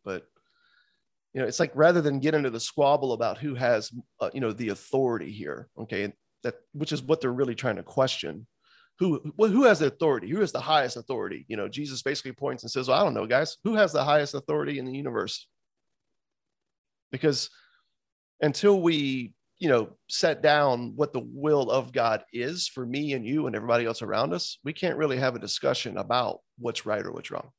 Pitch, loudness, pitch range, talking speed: 145 Hz, -27 LUFS, 130-155 Hz, 205 wpm